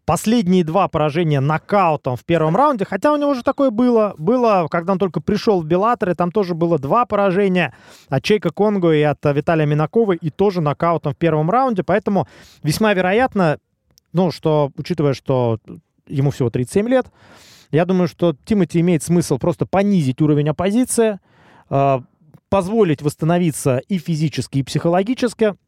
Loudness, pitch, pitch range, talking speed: -18 LUFS, 175 Hz, 150-200 Hz, 155 wpm